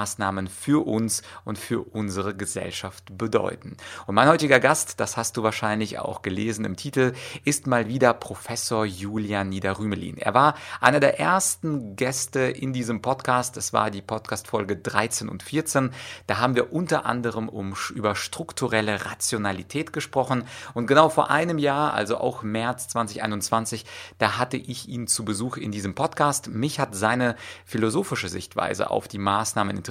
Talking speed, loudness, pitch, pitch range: 155 wpm, -24 LUFS, 115 Hz, 105-130 Hz